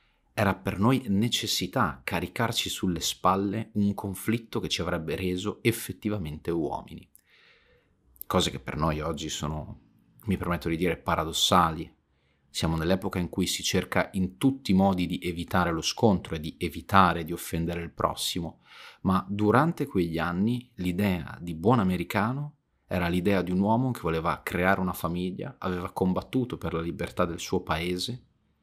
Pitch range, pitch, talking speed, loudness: 85-105 Hz, 90 Hz, 155 wpm, -28 LUFS